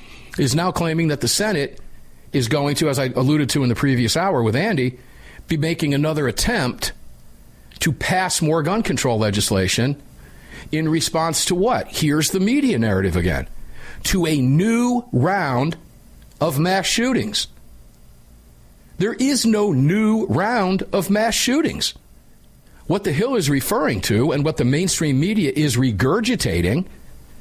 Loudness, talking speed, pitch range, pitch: -19 LUFS, 145 wpm, 125-190 Hz, 150 Hz